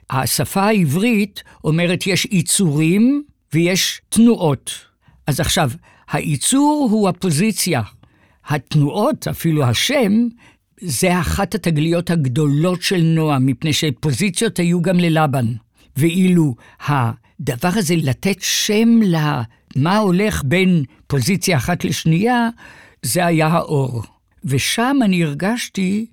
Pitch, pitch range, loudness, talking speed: 170 Hz, 145-200 Hz, -17 LUFS, 100 wpm